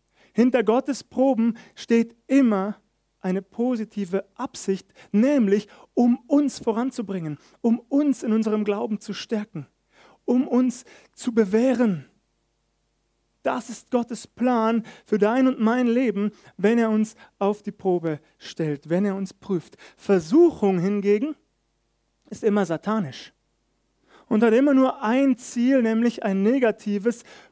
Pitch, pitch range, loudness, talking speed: 220 Hz, 200-245 Hz, -23 LUFS, 125 wpm